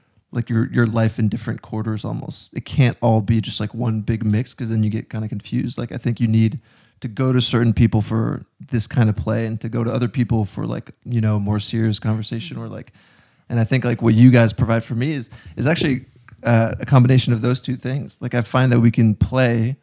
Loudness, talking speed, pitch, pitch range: -19 LUFS, 245 wpm, 115 Hz, 110-125 Hz